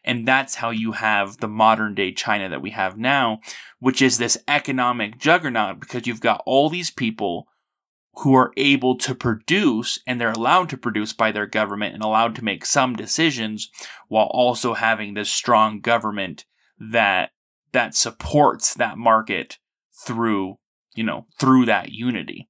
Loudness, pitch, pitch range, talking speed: -20 LUFS, 115 Hz, 110-130 Hz, 160 wpm